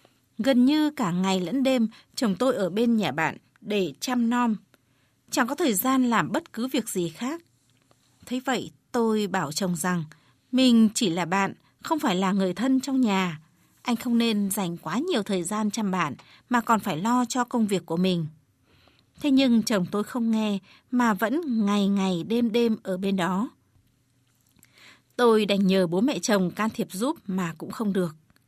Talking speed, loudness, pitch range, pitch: 190 wpm, -25 LUFS, 180-245 Hz, 210 Hz